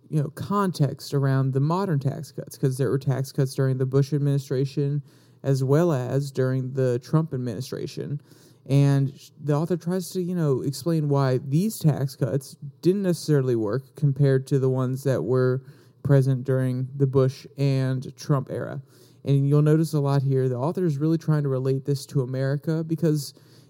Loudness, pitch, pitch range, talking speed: -24 LUFS, 140 Hz, 135-150 Hz, 175 wpm